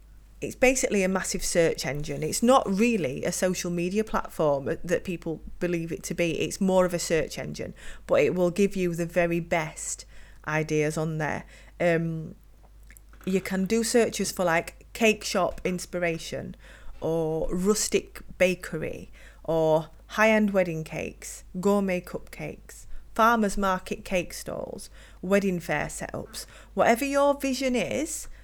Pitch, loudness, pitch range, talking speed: 185 Hz, -26 LUFS, 165-210 Hz, 140 wpm